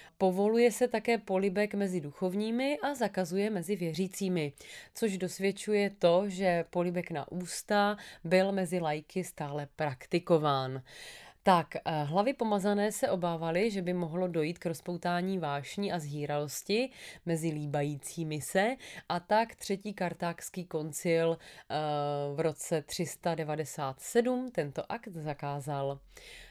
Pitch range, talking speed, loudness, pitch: 155-200 Hz, 115 wpm, -32 LUFS, 175 Hz